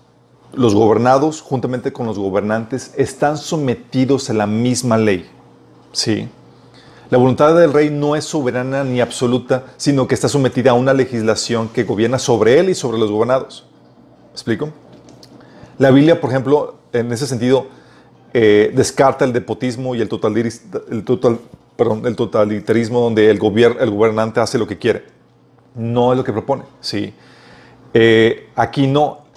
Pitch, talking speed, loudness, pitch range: 125 Hz, 155 wpm, -16 LUFS, 115-135 Hz